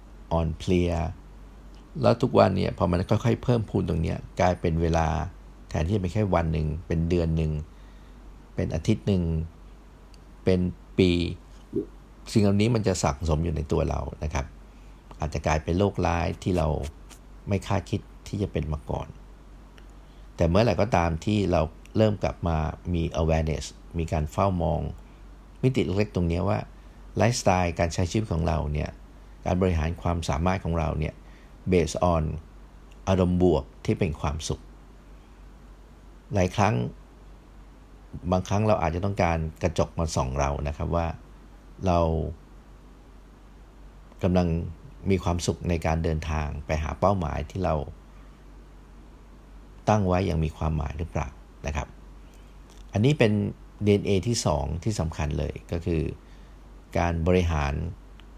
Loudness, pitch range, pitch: -26 LUFS, 75-95 Hz, 85 Hz